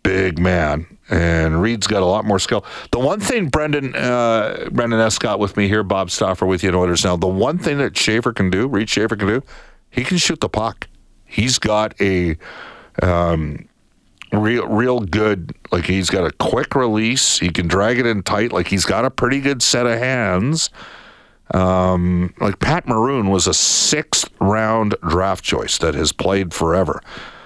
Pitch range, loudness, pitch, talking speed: 95-120 Hz, -17 LUFS, 105 Hz, 185 wpm